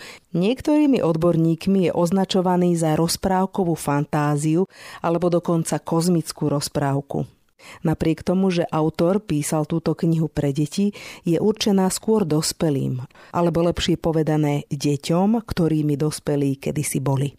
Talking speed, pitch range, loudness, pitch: 110 wpm, 150-180 Hz, -21 LUFS, 165 Hz